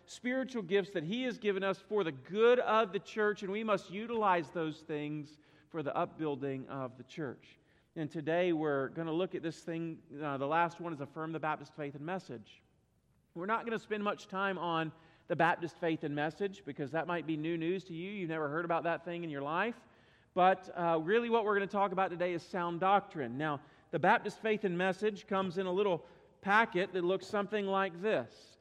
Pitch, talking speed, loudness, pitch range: 175 Hz, 220 wpm, -35 LUFS, 155-200 Hz